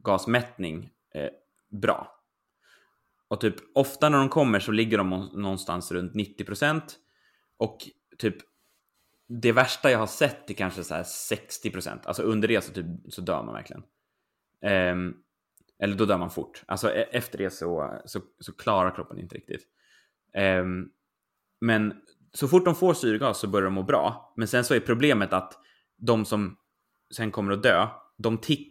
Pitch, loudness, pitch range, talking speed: 105 Hz, -26 LUFS, 95-120 Hz, 160 wpm